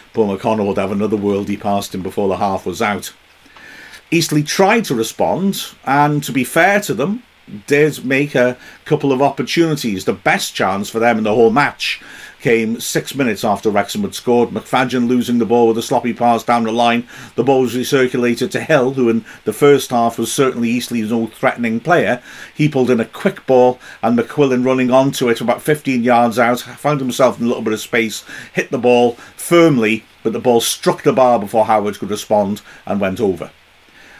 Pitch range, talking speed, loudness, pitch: 115-140 Hz, 200 wpm, -16 LUFS, 125 Hz